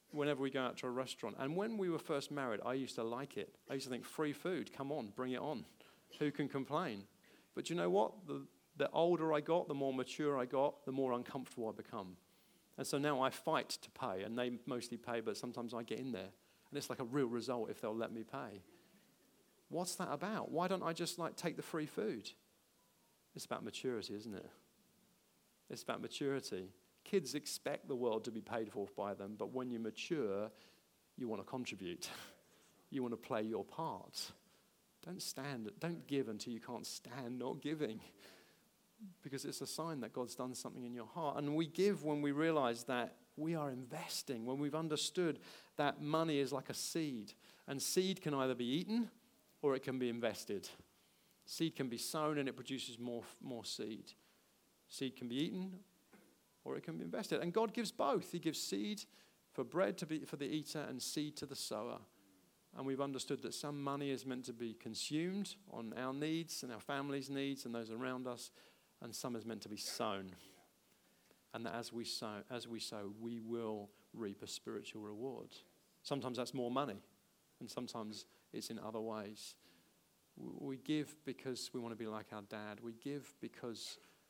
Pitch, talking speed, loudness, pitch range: 130 Hz, 200 wpm, -42 LUFS, 115-150 Hz